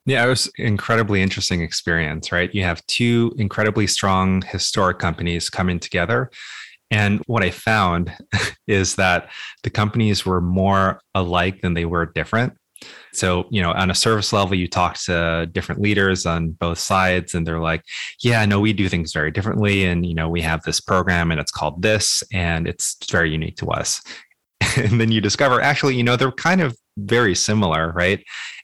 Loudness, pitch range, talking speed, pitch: -19 LUFS, 85-105 Hz, 180 wpm, 95 Hz